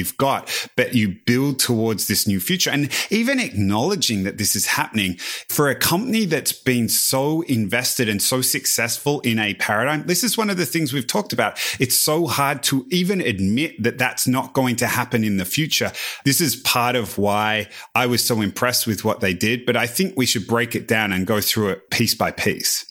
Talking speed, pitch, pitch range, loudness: 210 wpm, 125 Hz, 110-145 Hz, -19 LUFS